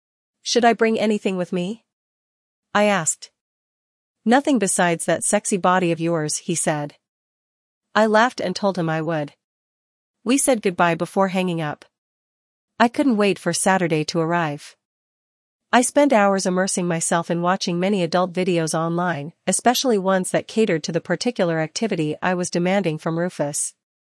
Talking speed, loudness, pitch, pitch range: 150 wpm, -20 LUFS, 185 Hz, 165-210 Hz